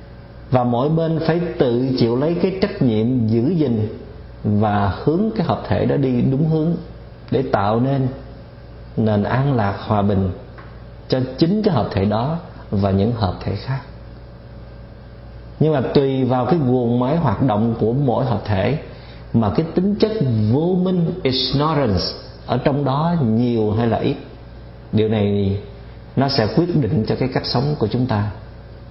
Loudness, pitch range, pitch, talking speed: -19 LUFS, 110-145 Hz, 120 Hz, 165 wpm